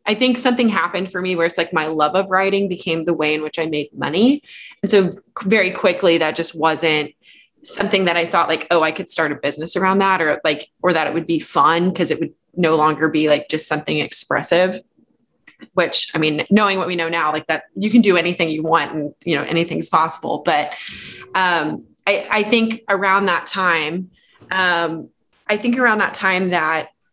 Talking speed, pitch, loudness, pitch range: 210 wpm, 170 Hz, -18 LUFS, 160-195 Hz